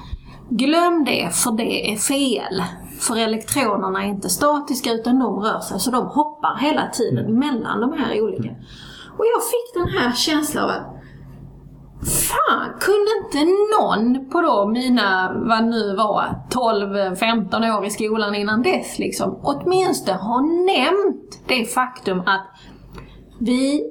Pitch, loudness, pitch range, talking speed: 250 Hz, -19 LUFS, 215-305 Hz, 145 wpm